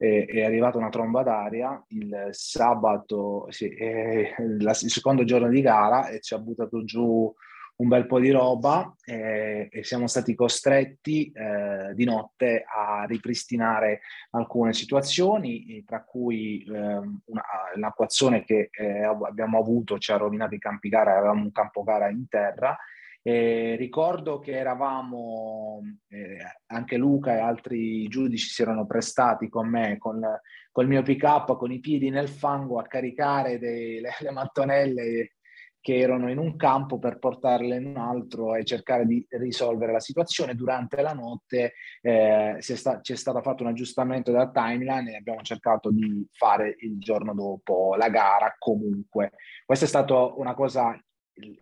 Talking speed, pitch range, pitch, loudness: 155 wpm, 110-130 Hz, 120 Hz, -25 LUFS